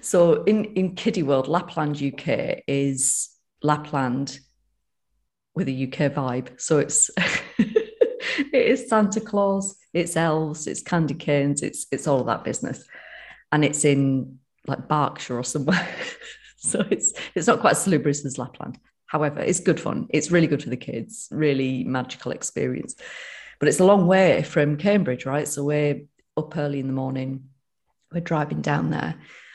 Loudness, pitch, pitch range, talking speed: -23 LUFS, 150 Hz, 140-190 Hz, 160 wpm